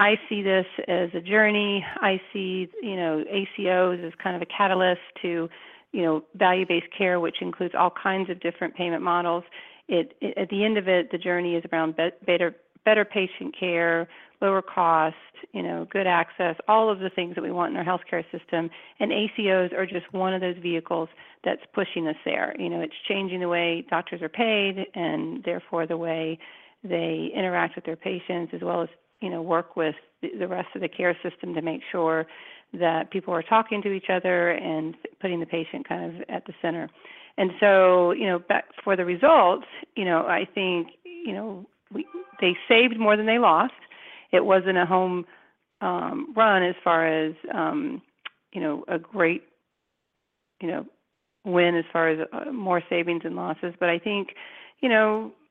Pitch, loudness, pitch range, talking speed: 180 Hz, -25 LUFS, 170-200 Hz, 185 wpm